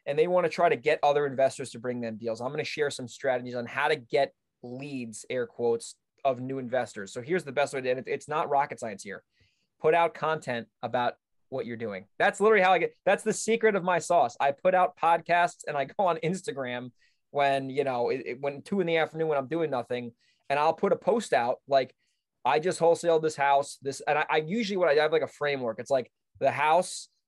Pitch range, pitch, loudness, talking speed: 125-170 Hz, 145 Hz, -28 LUFS, 240 wpm